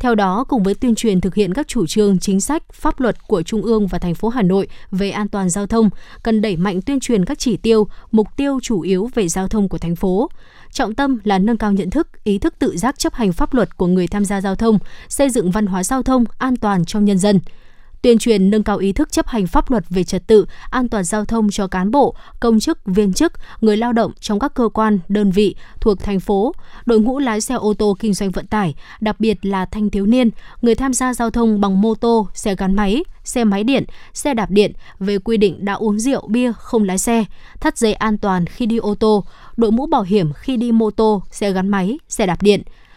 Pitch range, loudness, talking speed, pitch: 200-235 Hz, -17 LUFS, 250 wpm, 215 Hz